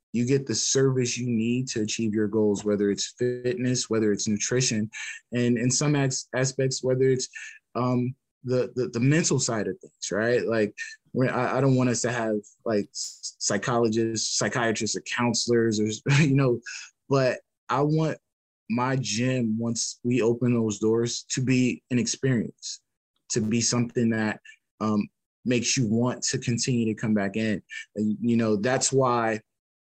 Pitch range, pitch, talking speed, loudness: 110-125 Hz, 120 Hz, 160 wpm, -25 LUFS